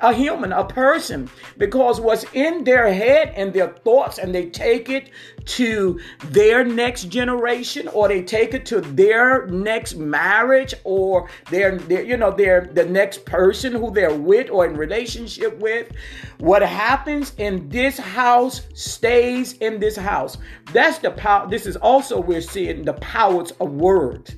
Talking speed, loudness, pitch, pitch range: 160 wpm, -18 LUFS, 230 Hz, 190-260 Hz